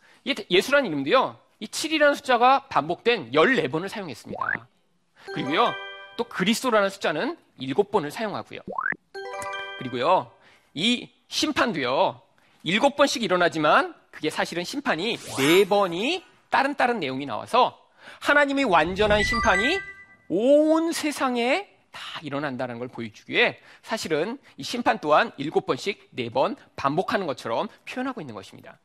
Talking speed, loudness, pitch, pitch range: 285 characters per minute, -24 LUFS, 235 Hz, 180-290 Hz